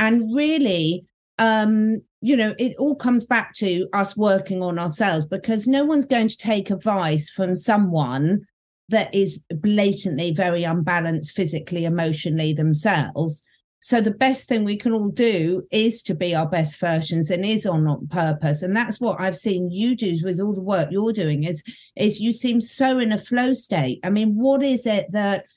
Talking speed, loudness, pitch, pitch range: 185 wpm, -21 LUFS, 200 Hz, 170-225 Hz